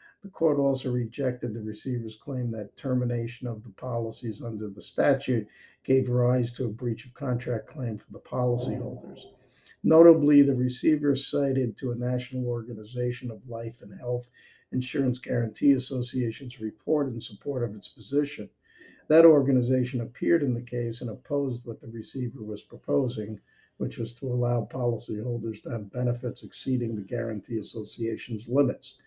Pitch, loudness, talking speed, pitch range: 125 Hz, -27 LUFS, 150 wpm, 115-130 Hz